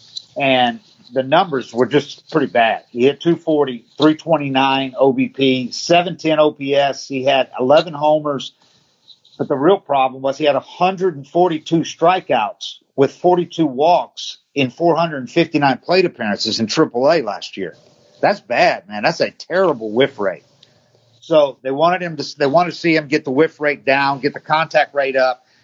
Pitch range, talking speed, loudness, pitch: 135-160 Hz, 155 wpm, -17 LUFS, 140 Hz